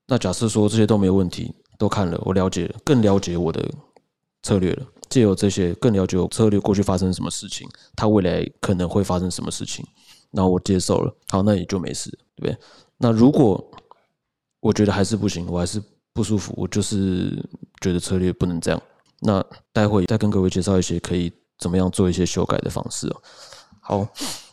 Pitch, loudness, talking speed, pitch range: 95 Hz, -21 LUFS, 300 characters per minute, 90-105 Hz